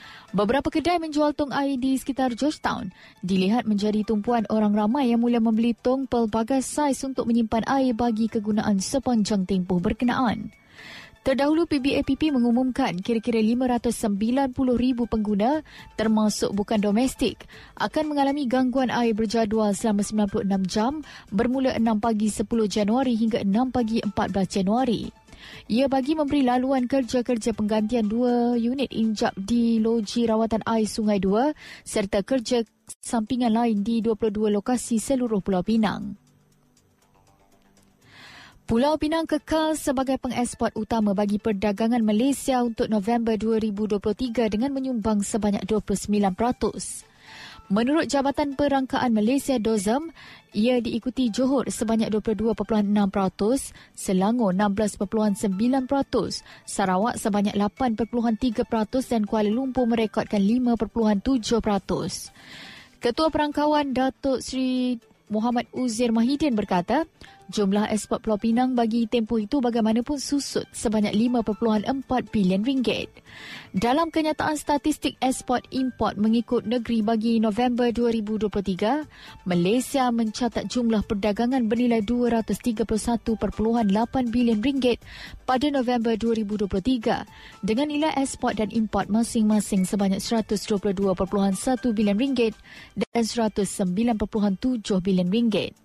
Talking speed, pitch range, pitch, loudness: 105 wpm, 215-255 Hz, 230 Hz, -24 LUFS